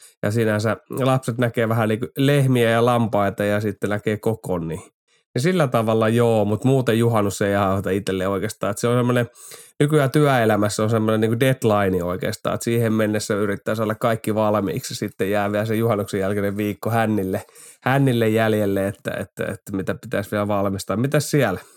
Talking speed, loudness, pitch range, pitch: 175 wpm, -21 LUFS, 100-120 Hz, 110 Hz